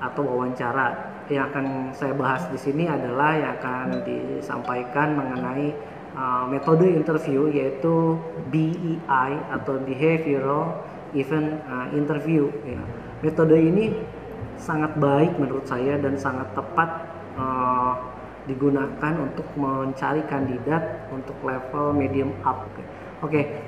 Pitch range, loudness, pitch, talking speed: 130-155 Hz, -24 LUFS, 140 Hz, 115 wpm